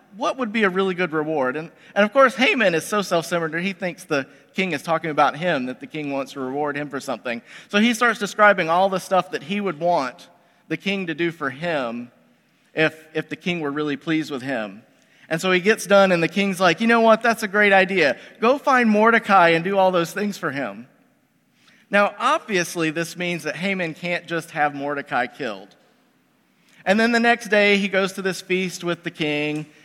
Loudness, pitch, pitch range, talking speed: -21 LUFS, 180 Hz, 155-205 Hz, 215 wpm